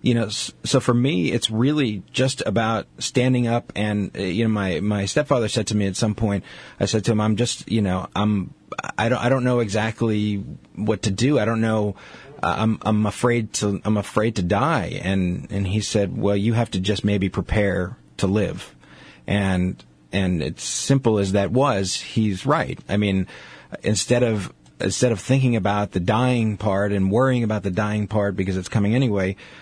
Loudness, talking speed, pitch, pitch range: -22 LUFS, 190 wpm, 105 Hz, 100-115 Hz